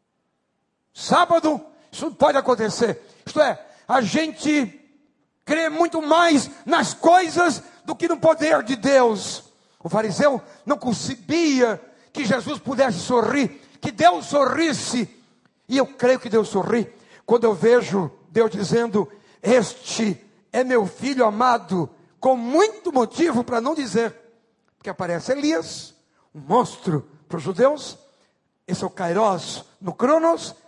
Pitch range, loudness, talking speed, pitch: 205-290 Hz, -21 LUFS, 130 wpm, 245 Hz